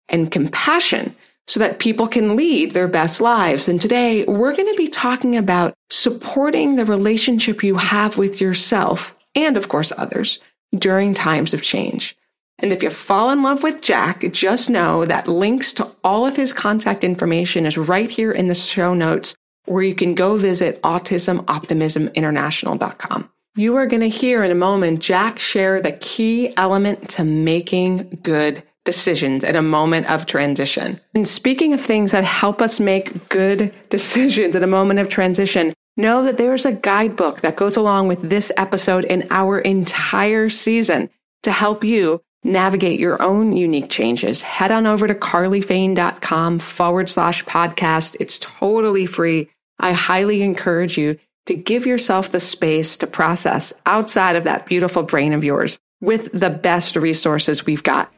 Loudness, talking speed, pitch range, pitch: -17 LUFS, 165 wpm, 175-220 Hz, 190 Hz